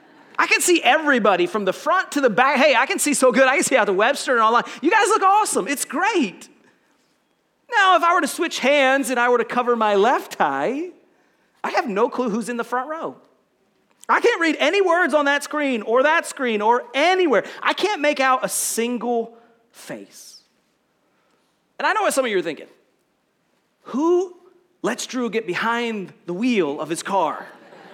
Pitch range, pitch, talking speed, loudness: 235-340 Hz, 270 Hz, 200 wpm, -19 LUFS